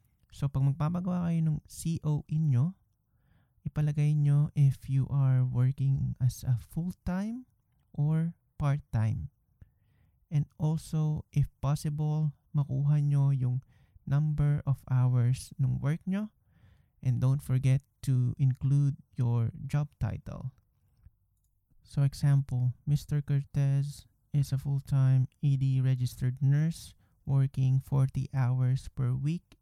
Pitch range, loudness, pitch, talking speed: 125-150 Hz, -30 LUFS, 135 Hz, 110 wpm